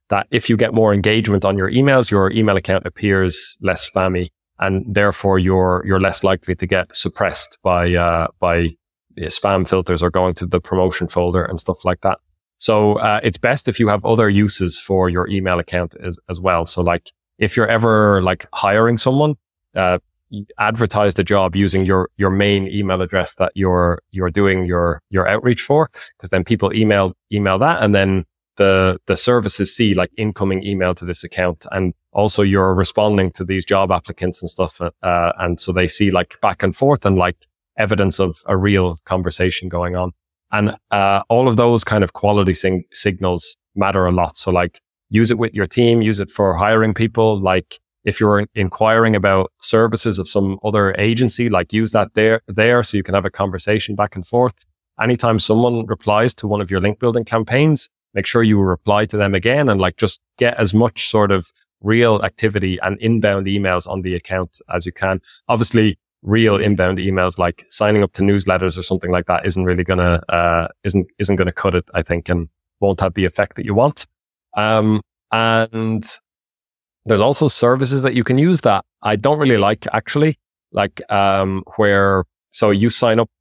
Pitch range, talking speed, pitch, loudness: 90-110 Hz, 195 wpm, 100 Hz, -17 LUFS